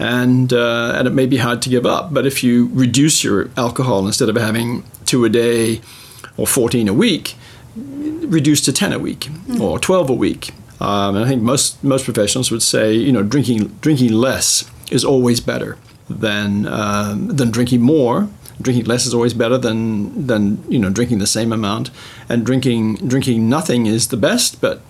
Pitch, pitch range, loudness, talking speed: 120 Hz, 110-130 Hz, -16 LUFS, 190 wpm